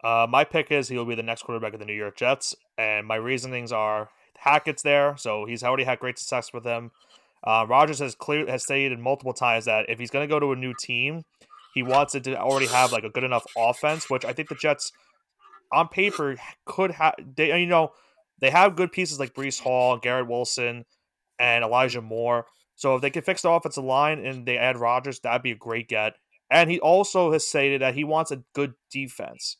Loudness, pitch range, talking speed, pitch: -24 LUFS, 120-150 Hz, 220 wpm, 130 Hz